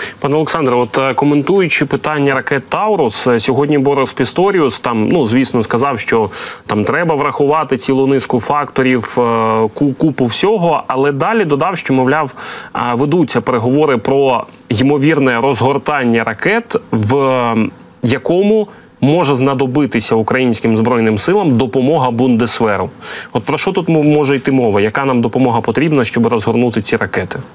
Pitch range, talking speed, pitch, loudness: 120-145 Hz, 125 wpm, 135 Hz, -13 LUFS